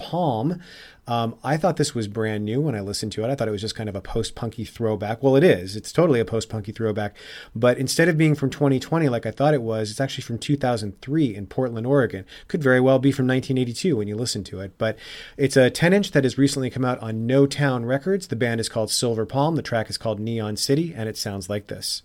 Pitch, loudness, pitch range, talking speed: 125 Hz, -23 LUFS, 110-140 Hz, 255 wpm